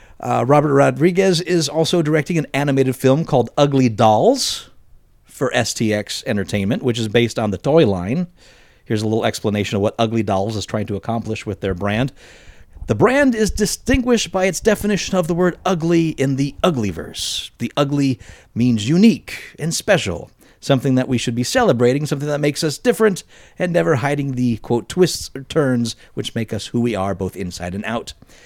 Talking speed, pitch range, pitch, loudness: 185 wpm, 110-165 Hz, 130 Hz, -18 LUFS